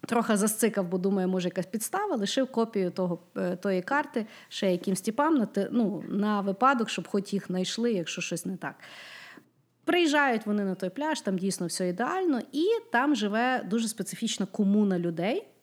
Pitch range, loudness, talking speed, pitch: 185-235 Hz, -28 LUFS, 155 wpm, 205 Hz